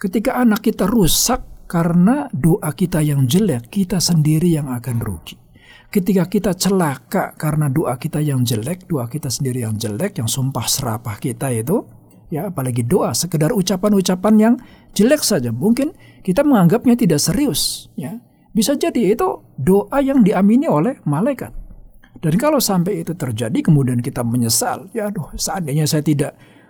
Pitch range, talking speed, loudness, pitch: 135-210 Hz, 150 wpm, -17 LUFS, 170 Hz